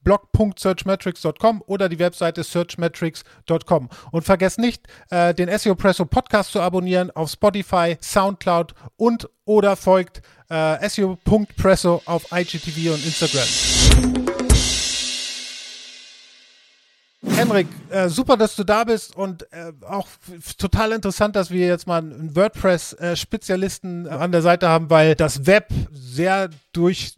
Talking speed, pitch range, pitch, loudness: 125 wpm, 165-200 Hz, 180 Hz, -19 LUFS